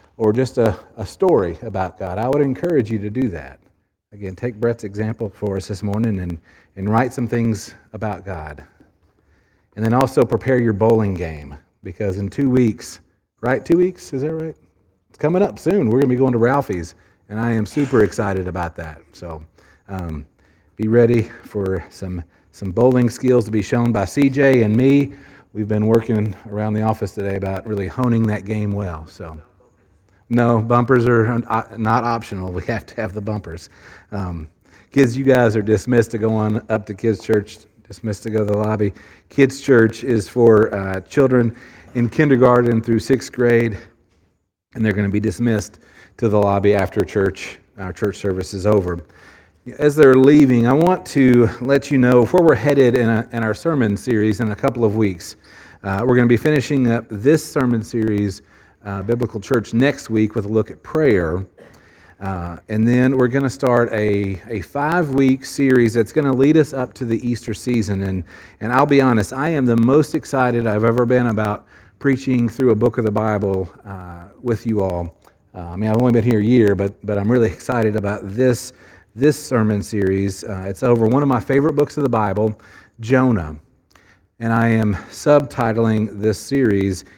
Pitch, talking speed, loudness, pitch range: 110 Hz, 190 wpm, -18 LUFS, 100-125 Hz